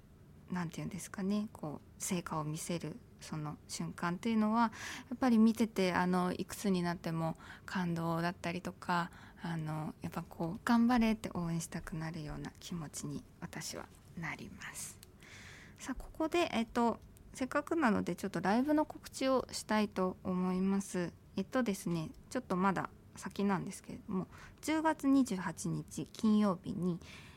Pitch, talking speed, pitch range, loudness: 190 Hz, 315 characters per minute, 175-230 Hz, -36 LUFS